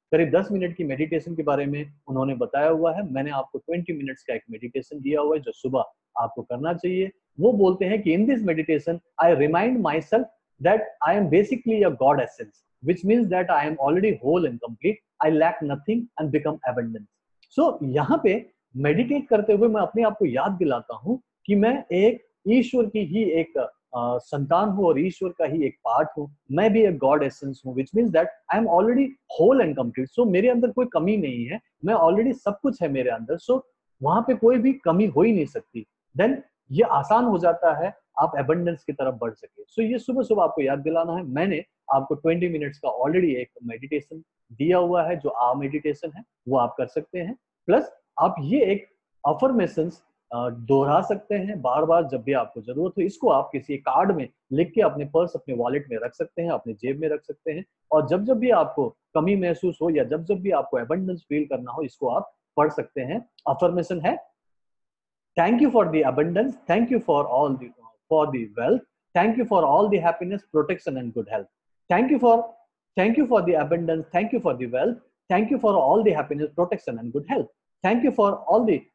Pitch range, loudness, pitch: 145-220 Hz, -23 LUFS, 170 Hz